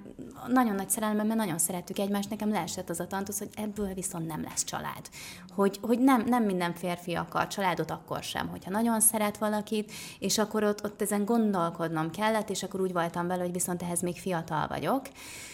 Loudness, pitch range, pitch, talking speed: -30 LUFS, 180-215 Hz, 200 Hz, 195 wpm